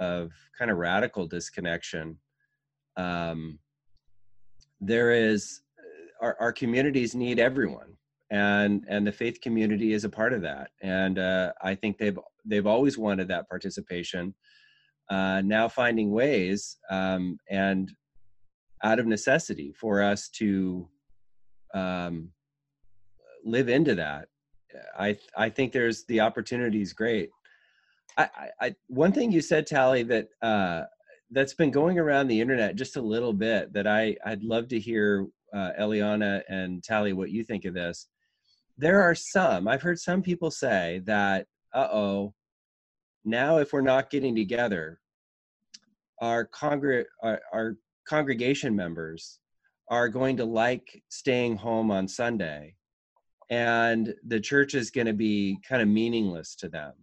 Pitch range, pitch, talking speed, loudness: 95-125 Hz, 110 Hz, 140 wpm, -27 LUFS